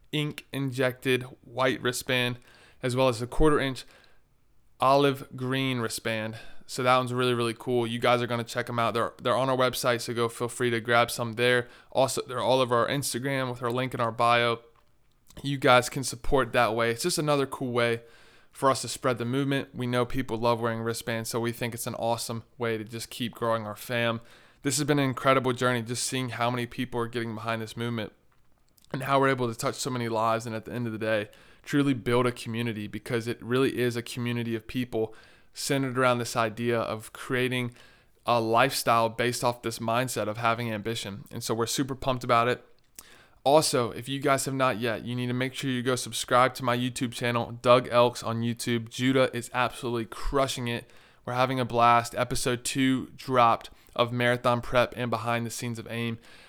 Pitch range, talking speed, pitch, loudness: 115-130 Hz, 210 wpm, 120 Hz, -27 LUFS